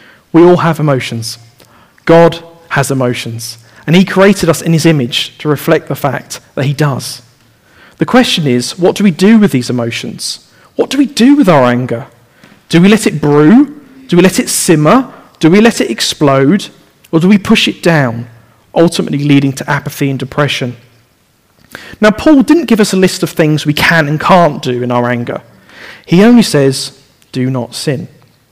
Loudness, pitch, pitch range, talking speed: -10 LUFS, 150 Hz, 125-185 Hz, 185 wpm